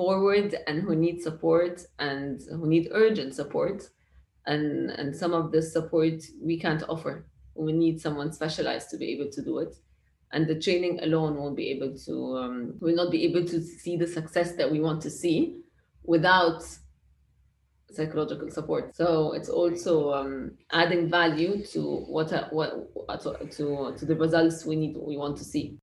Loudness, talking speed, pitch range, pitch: -28 LUFS, 170 wpm, 145-170 Hz, 160 Hz